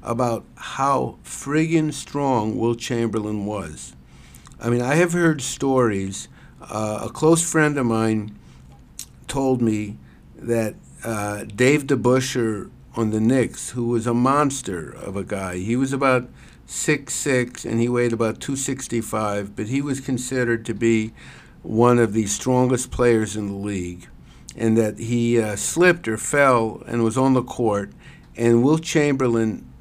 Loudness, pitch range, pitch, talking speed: -21 LUFS, 105-130 Hz, 115 Hz, 145 wpm